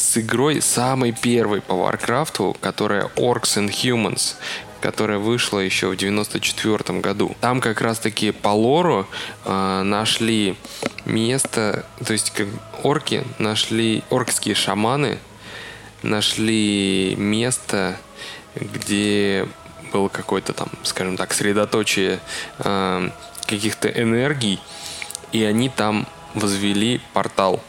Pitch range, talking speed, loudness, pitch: 100-115 Hz, 105 wpm, -20 LUFS, 105 Hz